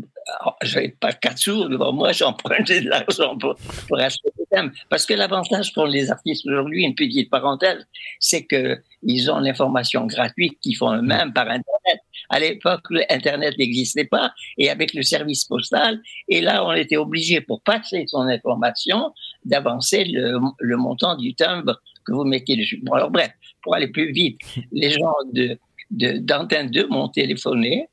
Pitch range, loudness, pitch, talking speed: 135-220 Hz, -20 LUFS, 155 Hz, 175 wpm